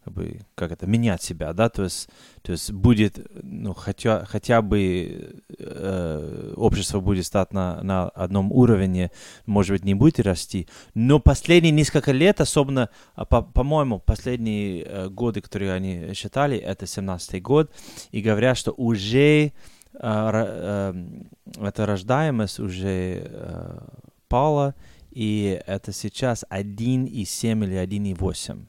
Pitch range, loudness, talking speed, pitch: 95-120 Hz, -23 LUFS, 135 wpm, 105 Hz